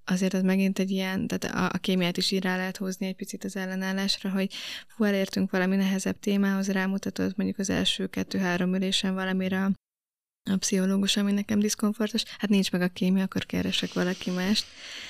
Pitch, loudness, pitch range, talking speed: 190 Hz, -27 LUFS, 185-200 Hz, 185 wpm